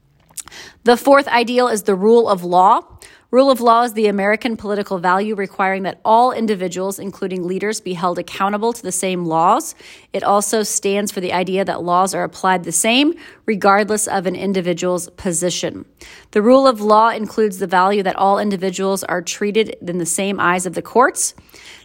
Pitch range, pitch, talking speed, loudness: 185-220 Hz, 195 Hz, 180 wpm, -17 LUFS